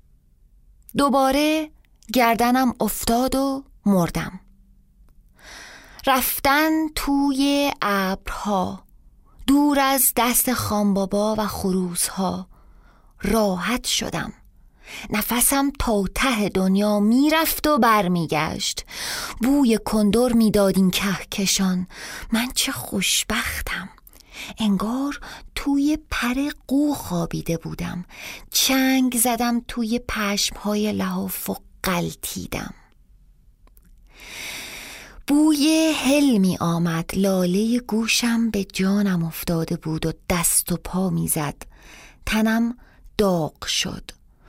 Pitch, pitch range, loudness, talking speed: 215 Hz, 185-265 Hz, -21 LUFS, 85 wpm